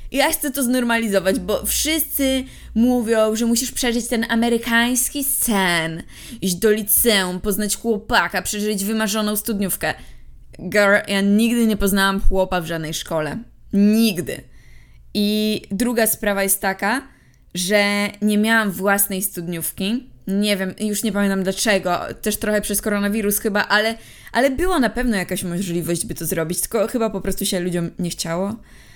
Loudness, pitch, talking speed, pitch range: -19 LUFS, 210 Hz, 145 wpm, 195-230 Hz